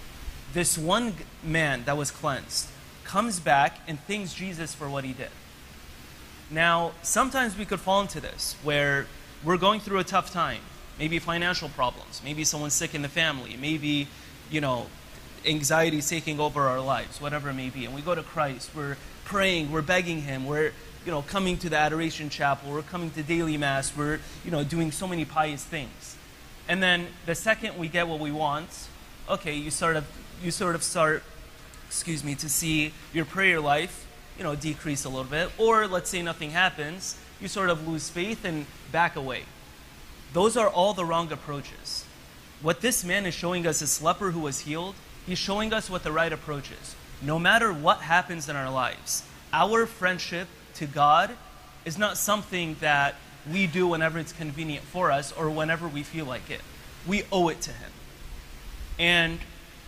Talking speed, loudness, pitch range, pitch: 185 wpm, -27 LUFS, 140-175 Hz, 155 Hz